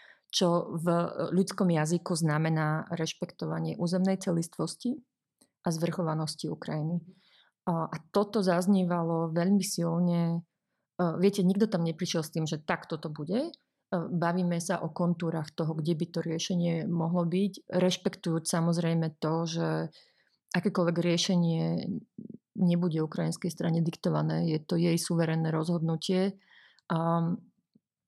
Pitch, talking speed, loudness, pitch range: 170 Hz, 110 wpm, -30 LUFS, 165-185 Hz